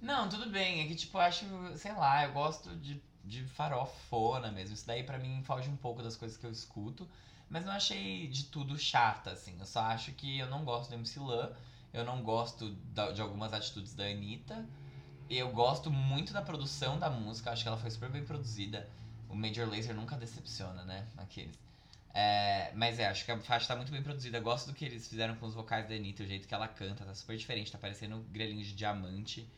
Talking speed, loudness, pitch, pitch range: 225 wpm, -37 LUFS, 115 Hz, 110-140 Hz